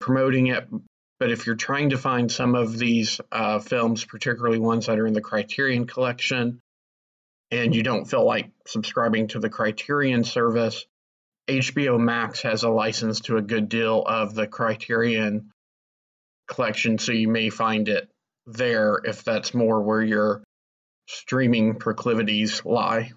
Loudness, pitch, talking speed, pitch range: -23 LUFS, 115 Hz, 150 wpm, 110-120 Hz